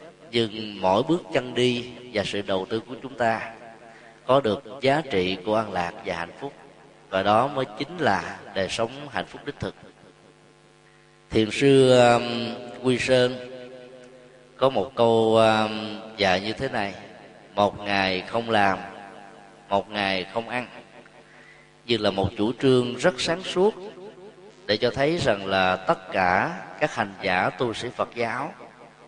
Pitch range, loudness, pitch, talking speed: 100-125 Hz, -24 LUFS, 115 Hz, 155 wpm